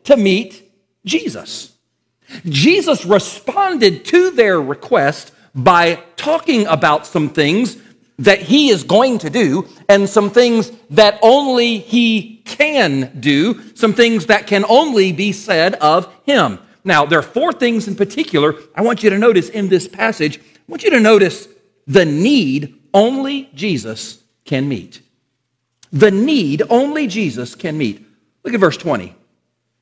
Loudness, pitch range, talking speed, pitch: -14 LUFS, 160-240 Hz, 145 wpm, 205 Hz